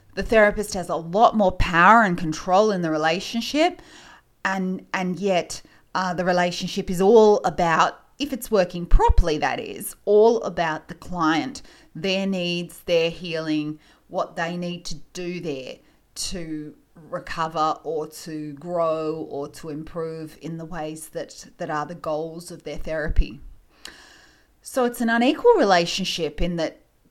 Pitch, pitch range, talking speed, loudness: 175 Hz, 160-195 Hz, 150 wpm, -22 LUFS